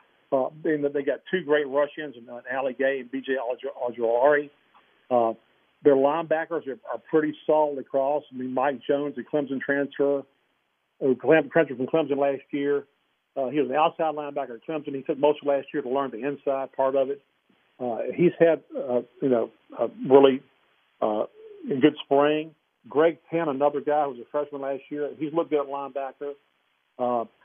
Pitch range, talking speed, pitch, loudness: 135-150 Hz, 190 wpm, 145 Hz, -25 LUFS